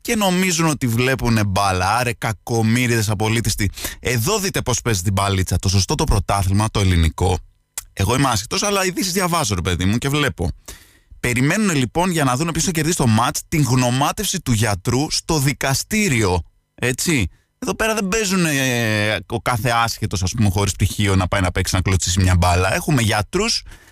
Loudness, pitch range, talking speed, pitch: -19 LUFS, 100-150 Hz, 175 wpm, 115 Hz